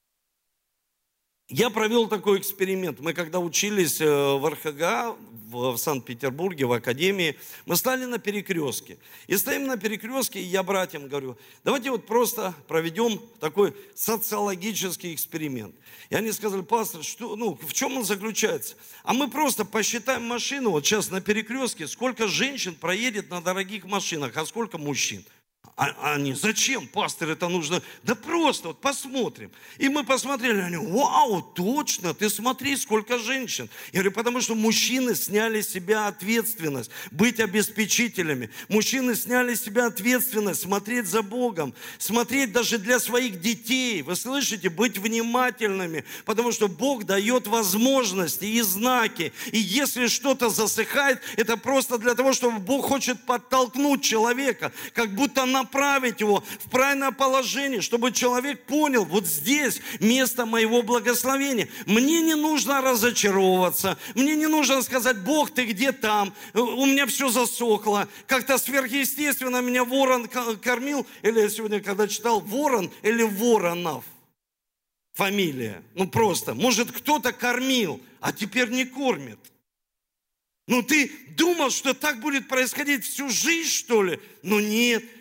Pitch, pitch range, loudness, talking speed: 230 Hz, 195-255 Hz, -24 LUFS, 140 wpm